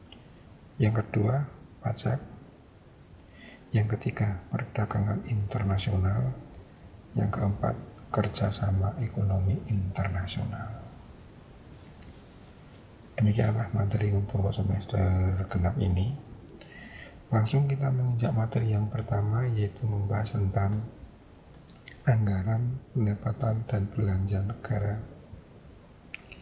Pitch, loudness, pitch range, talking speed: 110 Hz, -29 LUFS, 100-115 Hz, 75 wpm